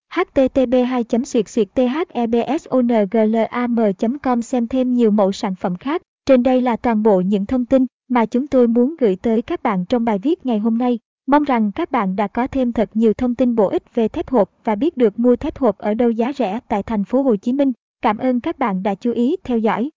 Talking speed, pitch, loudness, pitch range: 215 wpm, 240 Hz, -18 LUFS, 220-255 Hz